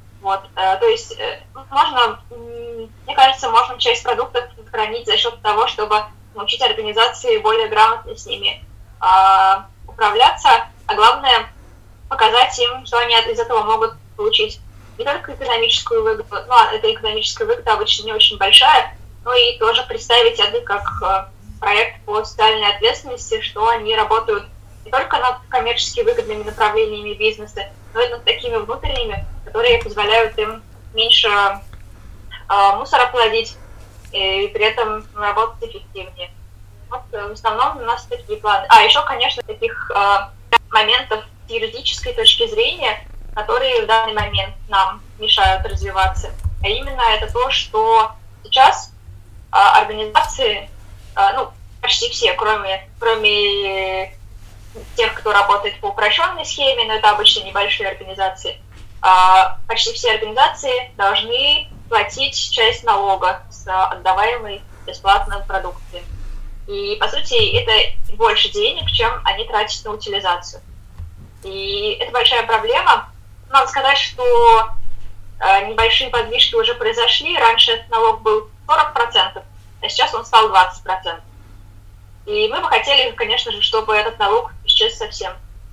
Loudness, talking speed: -15 LUFS, 130 wpm